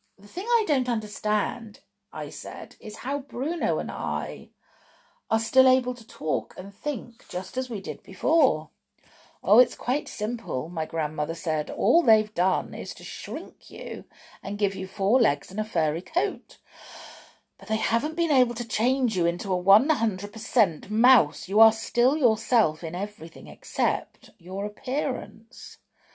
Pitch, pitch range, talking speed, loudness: 220 Hz, 190-250 Hz, 160 wpm, -26 LUFS